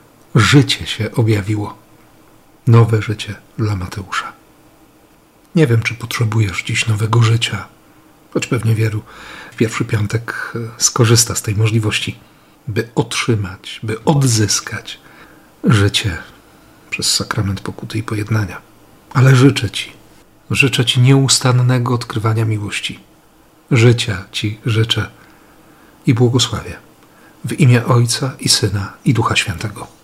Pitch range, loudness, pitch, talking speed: 110-130 Hz, -15 LUFS, 115 Hz, 110 wpm